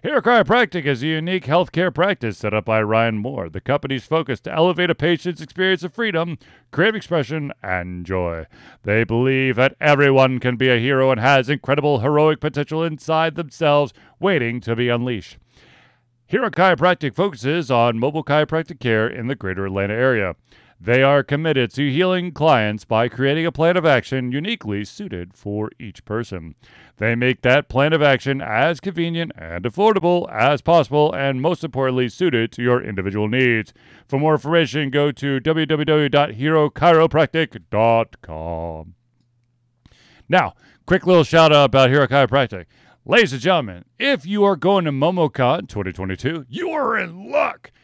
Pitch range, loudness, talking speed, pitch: 120-165 Hz, -19 LUFS, 155 wpm, 140 Hz